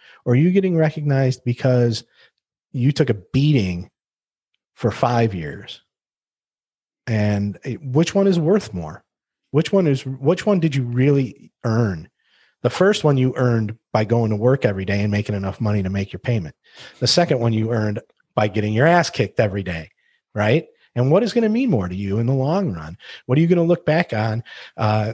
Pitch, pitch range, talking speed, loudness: 125 Hz, 105-155 Hz, 195 wpm, -20 LUFS